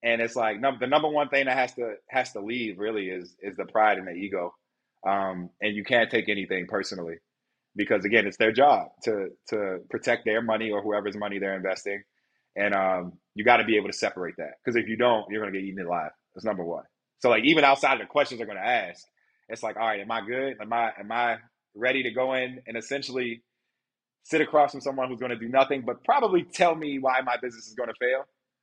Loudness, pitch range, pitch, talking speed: -26 LUFS, 105-130 Hz, 115 Hz, 240 wpm